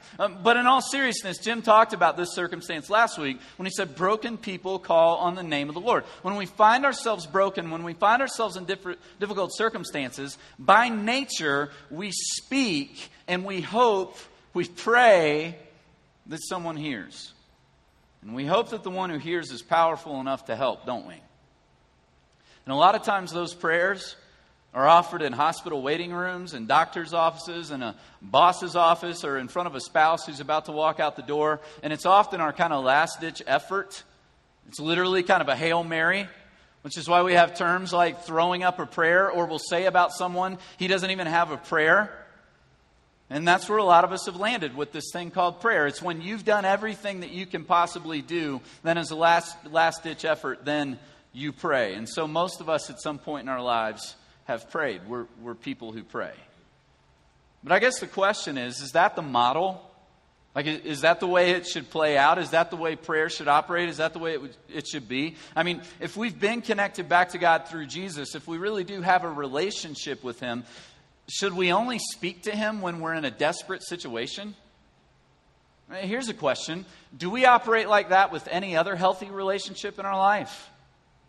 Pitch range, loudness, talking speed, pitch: 155-195 Hz, -25 LUFS, 200 wpm, 175 Hz